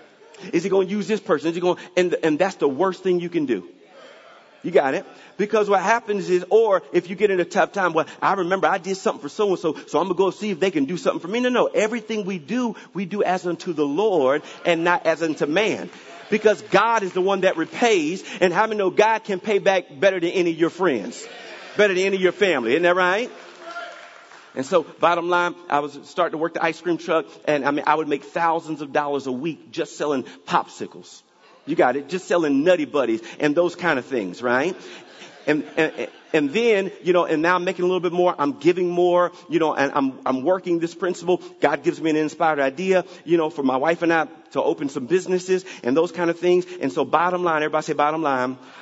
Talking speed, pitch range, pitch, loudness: 240 wpm, 160-195 Hz, 175 Hz, -21 LUFS